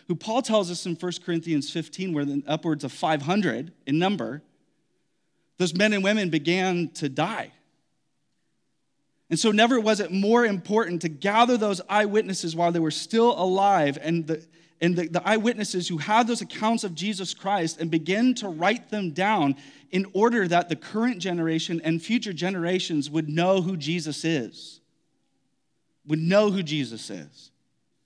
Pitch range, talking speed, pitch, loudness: 160-205 Hz, 165 wpm, 180 Hz, -25 LUFS